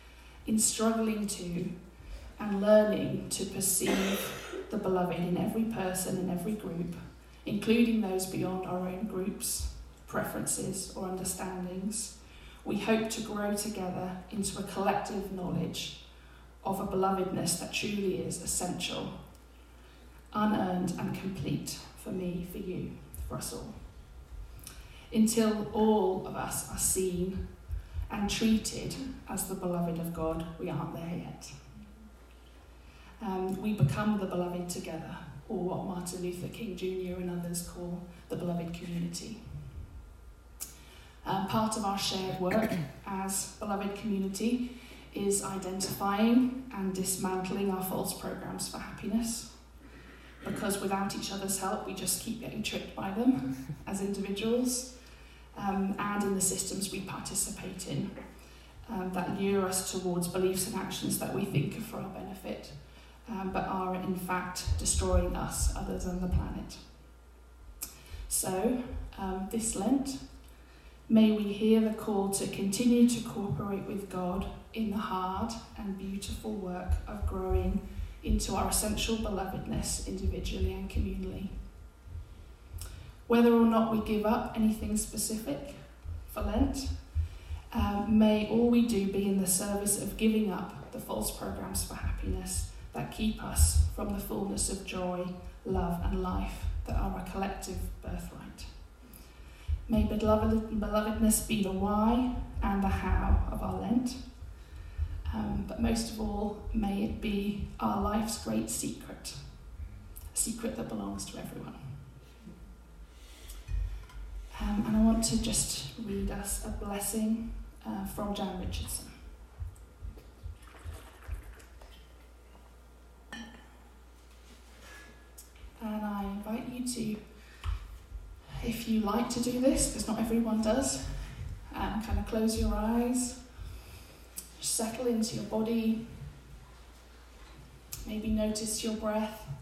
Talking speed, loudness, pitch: 130 wpm, -32 LUFS, 185 Hz